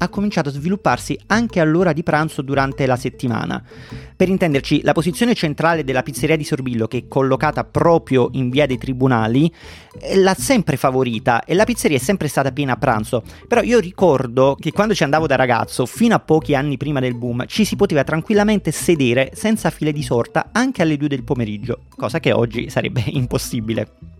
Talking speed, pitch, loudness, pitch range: 185 wpm, 145 Hz, -18 LUFS, 125-170 Hz